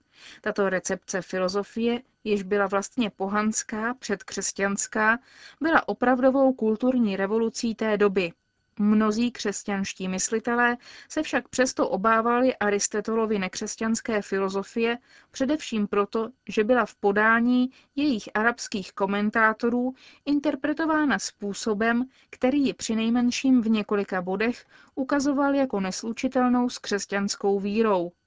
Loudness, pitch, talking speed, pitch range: -25 LUFS, 225 Hz, 100 wpm, 205-250 Hz